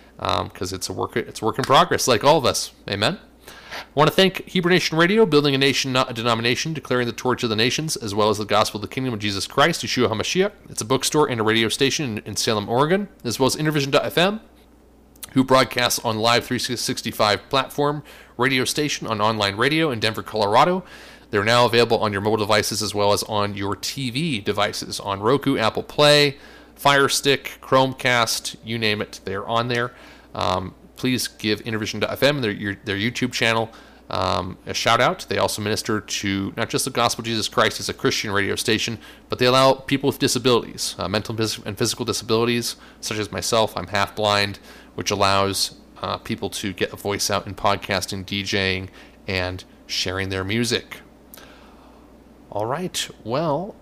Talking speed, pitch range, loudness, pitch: 185 wpm, 105-130 Hz, -21 LUFS, 115 Hz